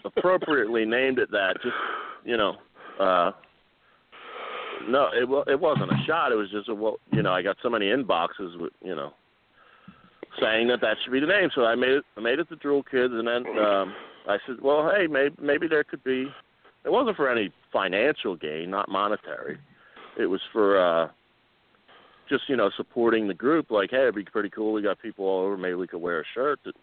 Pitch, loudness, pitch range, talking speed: 125 Hz, -25 LUFS, 110-145 Hz, 210 wpm